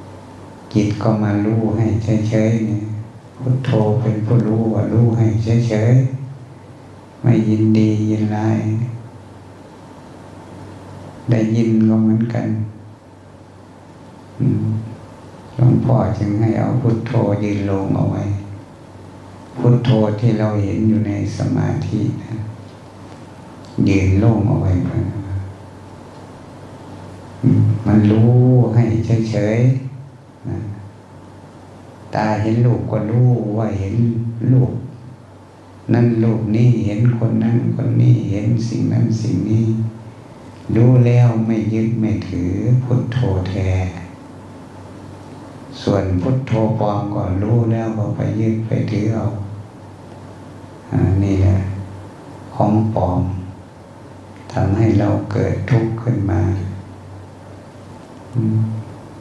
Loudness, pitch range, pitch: -17 LUFS, 100-120 Hz, 110 Hz